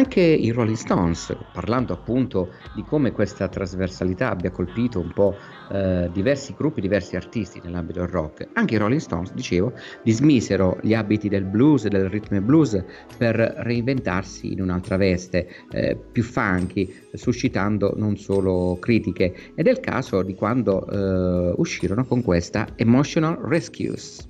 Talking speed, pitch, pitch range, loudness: 150 wpm, 100 Hz, 90-120 Hz, -22 LUFS